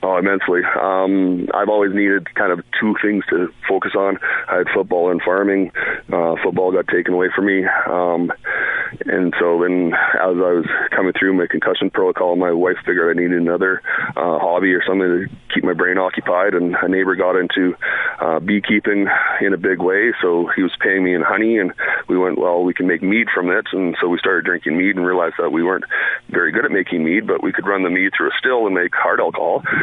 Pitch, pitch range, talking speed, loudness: 90 Hz, 90-95 Hz, 220 wpm, -17 LUFS